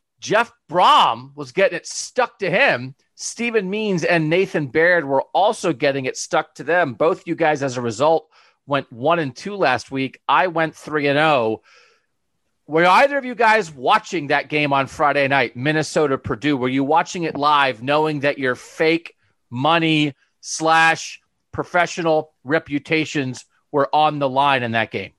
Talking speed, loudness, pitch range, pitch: 165 wpm, -19 LUFS, 140-170 Hz, 155 Hz